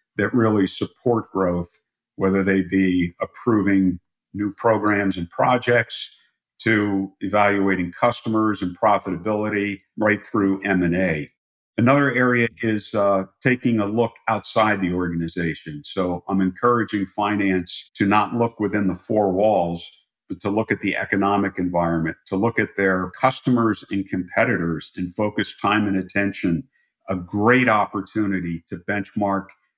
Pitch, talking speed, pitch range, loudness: 100 Hz, 135 wpm, 95-110 Hz, -21 LUFS